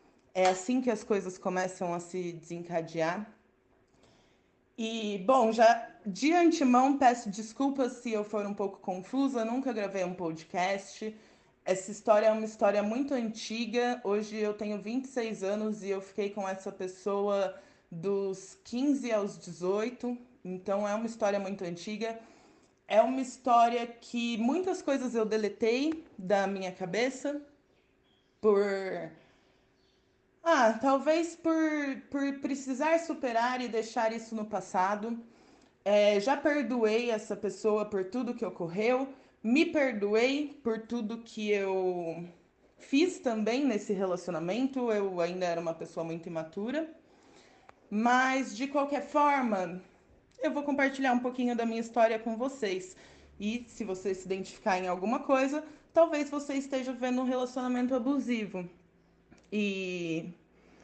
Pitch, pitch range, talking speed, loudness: 220 Hz, 195-255 Hz, 130 wpm, -31 LUFS